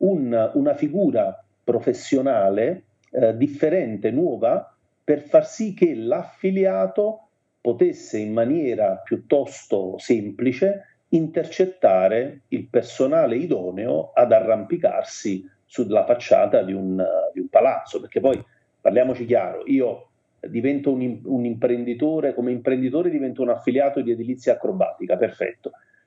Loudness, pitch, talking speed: -22 LUFS, 150 Hz, 110 wpm